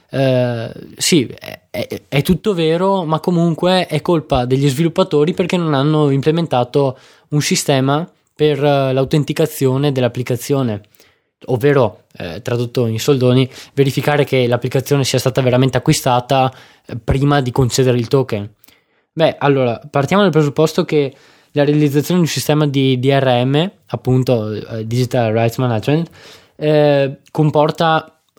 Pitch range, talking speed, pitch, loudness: 125-155 Hz, 120 wpm, 140 Hz, -16 LUFS